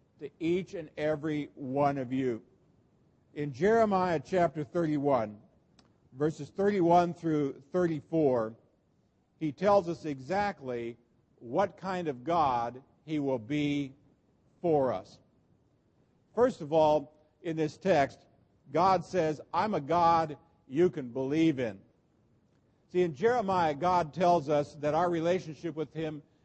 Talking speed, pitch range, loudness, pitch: 125 wpm, 140-175 Hz, -30 LUFS, 155 Hz